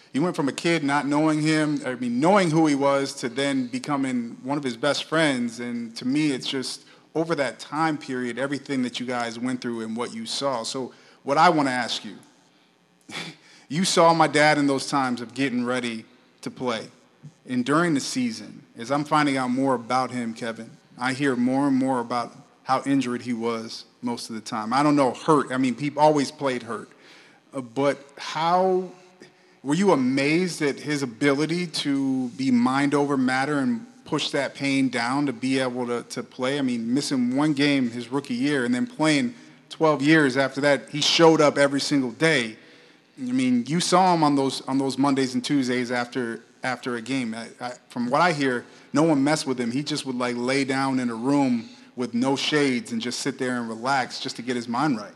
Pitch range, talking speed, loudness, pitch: 125-155 Hz, 210 wpm, -24 LUFS, 140 Hz